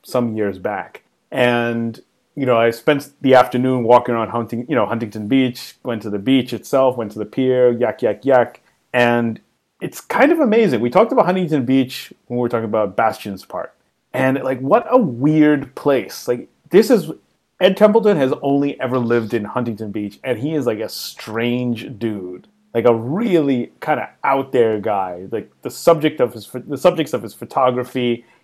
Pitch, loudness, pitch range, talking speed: 125 Hz, -18 LUFS, 115-140 Hz, 190 wpm